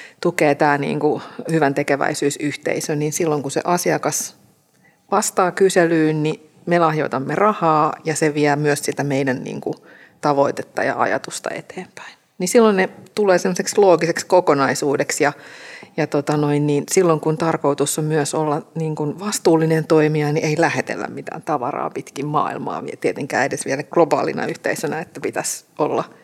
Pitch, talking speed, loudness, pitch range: 155 Hz, 150 wpm, -19 LUFS, 145-175 Hz